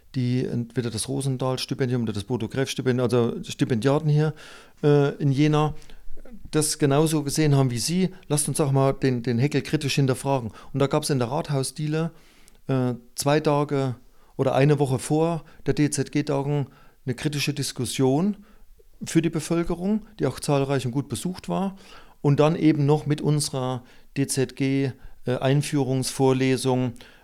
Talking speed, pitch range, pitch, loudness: 140 wpm, 130-150 Hz, 140 Hz, -24 LUFS